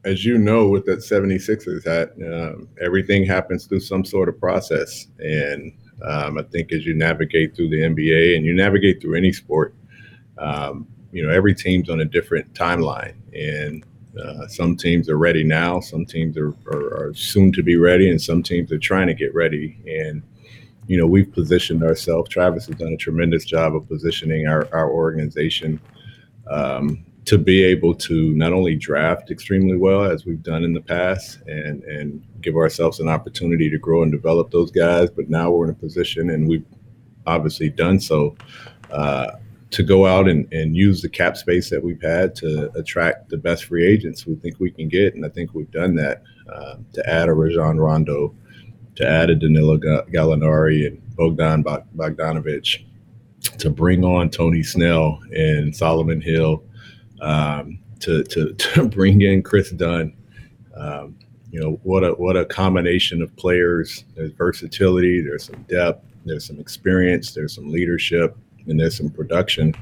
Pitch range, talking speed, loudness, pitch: 80-95 Hz, 175 wpm, -19 LUFS, 85 Hz